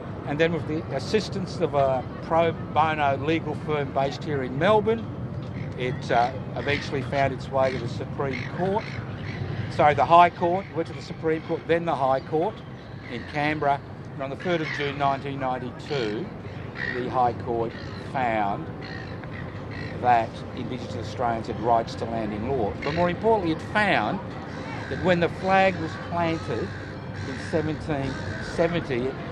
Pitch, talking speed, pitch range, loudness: 140 Hz, 150 wpm, 125-160 Hz, -26 LUFS